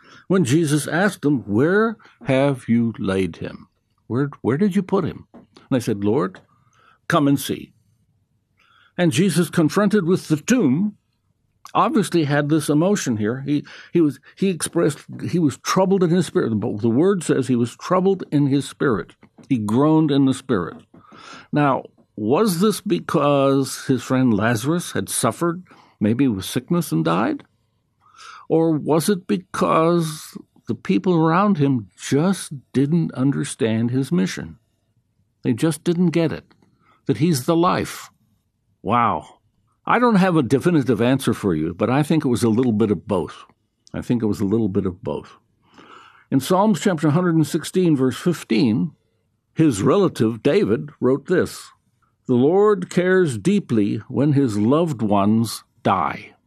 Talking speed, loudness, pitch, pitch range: 150 wpm, -20 LUFS, 150 Hz, 120-180 Hz